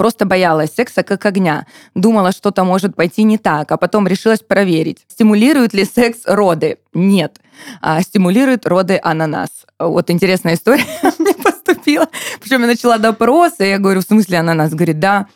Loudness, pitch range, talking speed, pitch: -13 LUFS, 175-240 Hz, 160 wpm, 200 Hz